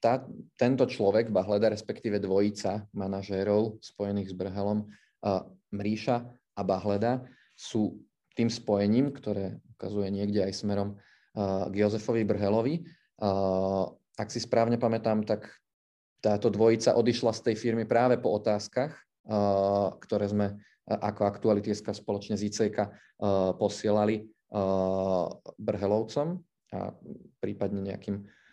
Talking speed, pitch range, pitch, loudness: 120 wpm, 100-115 Hz, 105 Hz, -29 LUFS